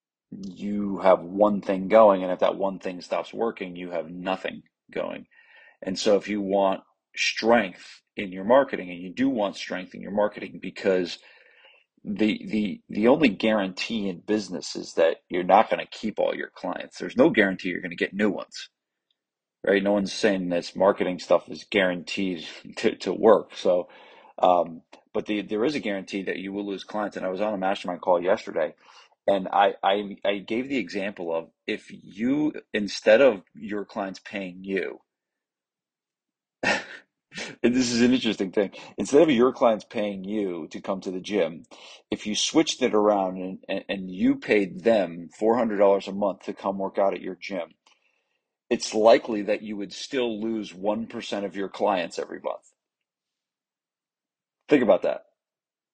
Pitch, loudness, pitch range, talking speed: 100 Hz, -25 LUFS, 95-110 Hz, 180 wpm